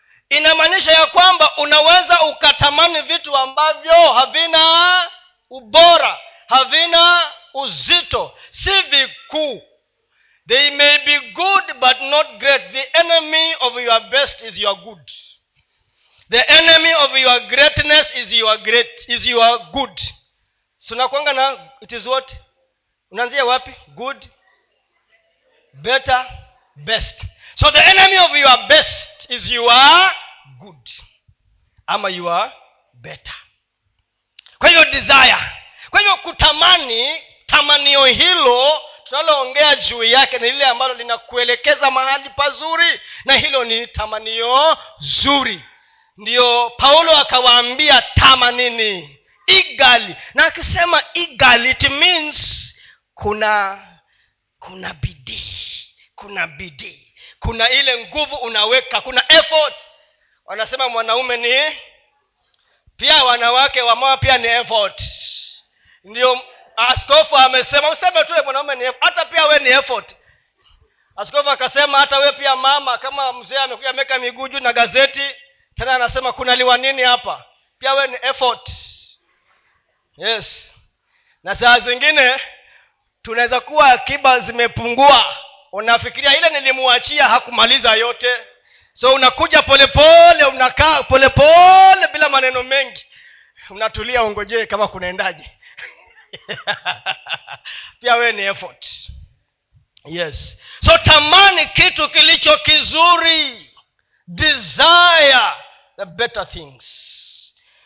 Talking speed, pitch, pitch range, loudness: 95 wpm, 270 Hz, 245-310 Hz, -12 LUFS